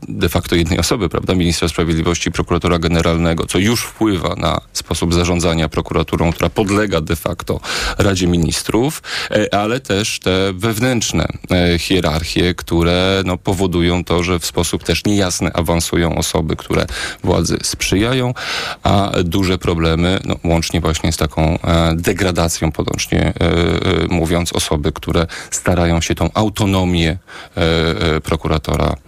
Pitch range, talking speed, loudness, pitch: 85-95 Hz, 120 wpm, -16 LUFS, 85 Hz